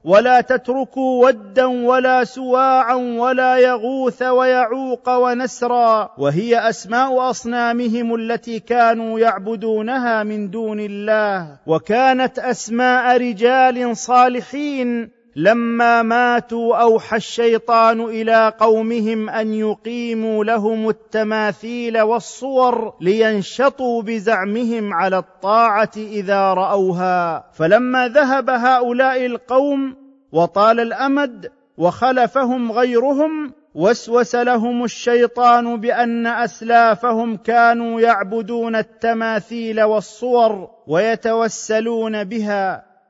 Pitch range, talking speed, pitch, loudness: 220-250 Hz, 80 wpm, 235 Hz, -17 LUFS